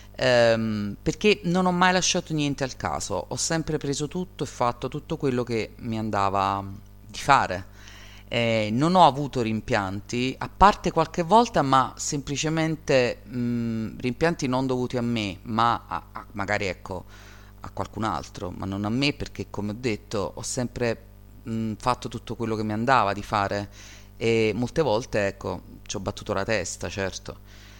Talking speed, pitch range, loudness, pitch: 160 wpm, 100-135 Hz, -25 LUFS, 110 Hz